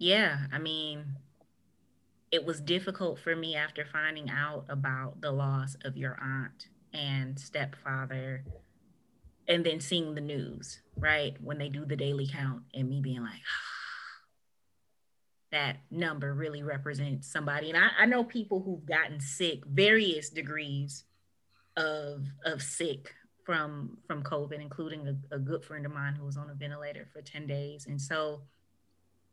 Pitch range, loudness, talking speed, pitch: 135-155 Hz, -32 LUFS, 150 wpm, 145 Hz